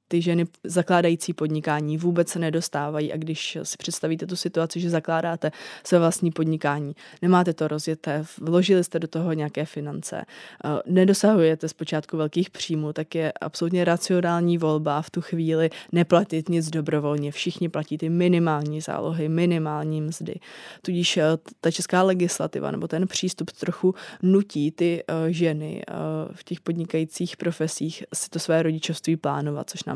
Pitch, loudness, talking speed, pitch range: 165 Hz, -24 LUFS, 140 wpm, 155-175 Hz